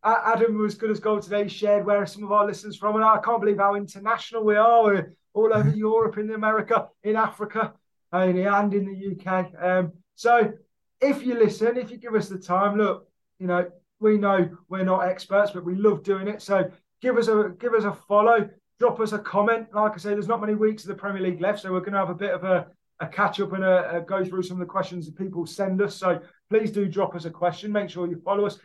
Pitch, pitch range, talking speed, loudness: 205 Hz, 185-215 Hz, 260 wpm, -24 LUFS